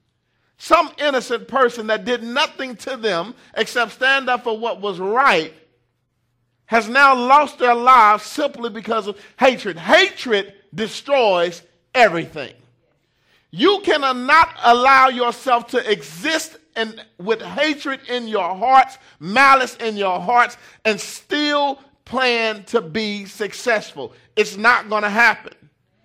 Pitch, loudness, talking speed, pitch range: 230 Hz, -17 LUFS, 125 wpm, 205-265 Hz